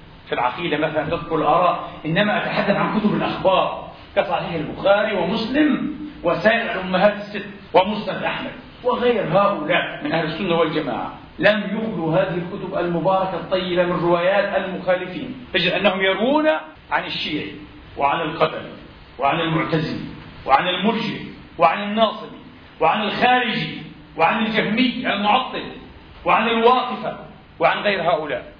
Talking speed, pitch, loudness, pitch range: 115 wpm, 200 Hz, -20 LUFS, 175-225 Hz